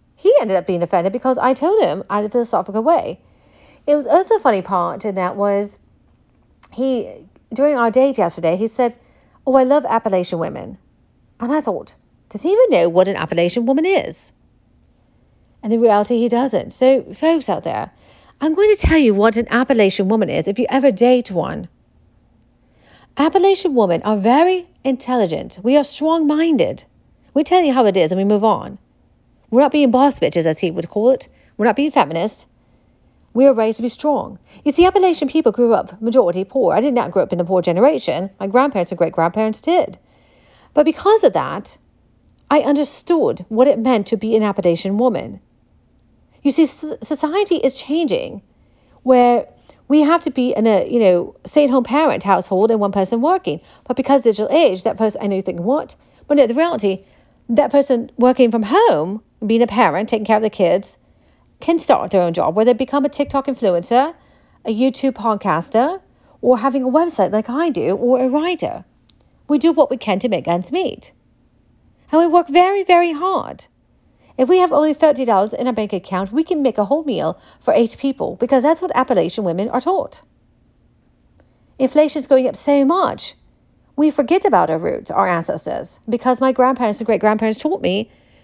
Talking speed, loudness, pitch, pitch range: 190 wpm, -16 LUFS, 255 Hz, 215-295 Hz